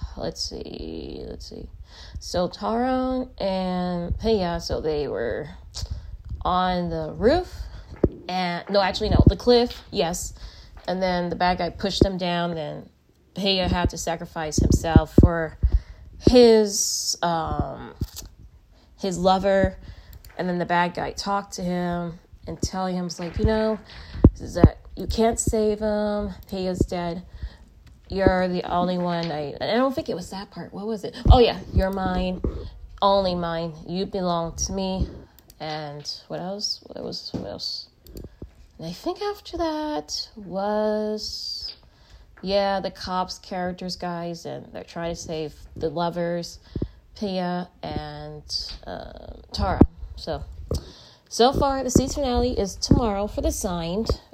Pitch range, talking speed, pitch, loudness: 165-205 Hz, 145 wpm, 180 Hz, -24 LUFS